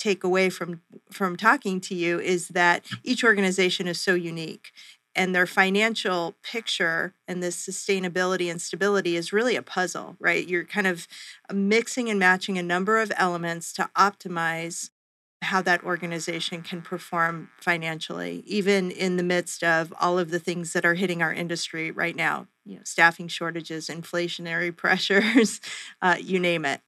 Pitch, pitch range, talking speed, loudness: 180 Hz, 170-195 Hz, 160 wpm, -24 LUFS